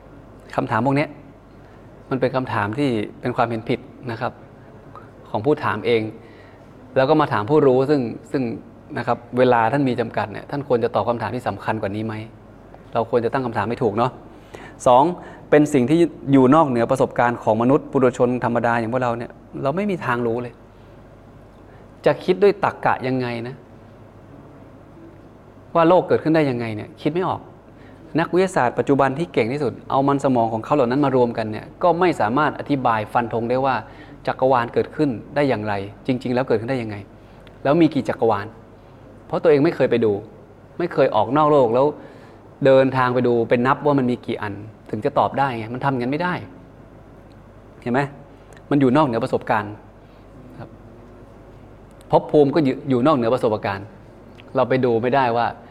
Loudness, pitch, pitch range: -20 LUFS, 125 Hz, 110-140 Hz